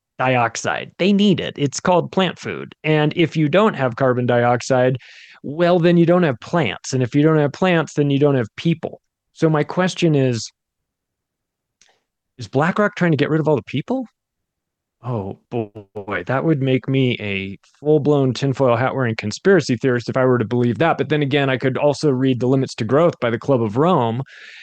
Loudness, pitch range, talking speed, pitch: -18 LUFS, 125-165 Hz, 200 wpm, 140 Hz